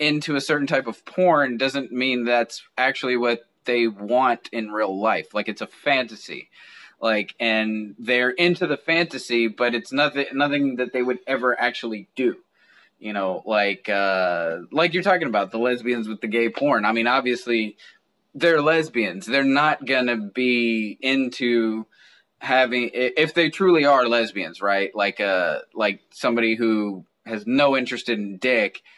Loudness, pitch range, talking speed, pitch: -22 LUFS, 110-135 Hz, 160 wpm, 120 Hz